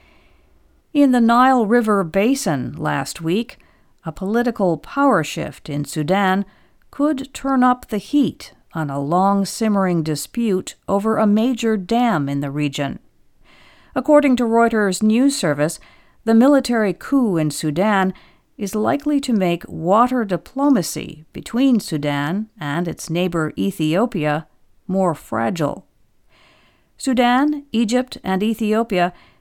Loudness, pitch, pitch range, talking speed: -19 LUFS, 200 Hz, 160-240 Hz, 120 wpm